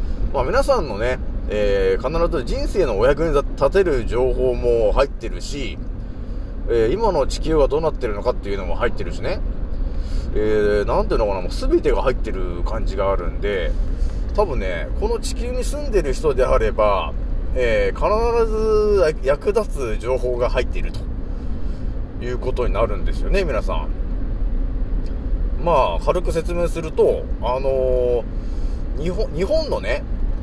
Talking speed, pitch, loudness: 290 characters per minute, 125 Hz, -21 LUFS